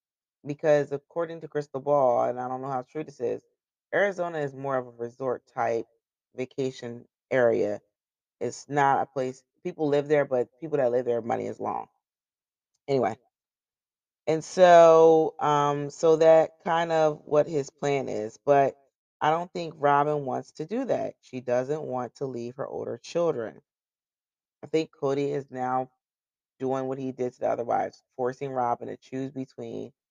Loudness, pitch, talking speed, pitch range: -26 LUFS, 140 Hz, 165 wpm, 130-155 Hz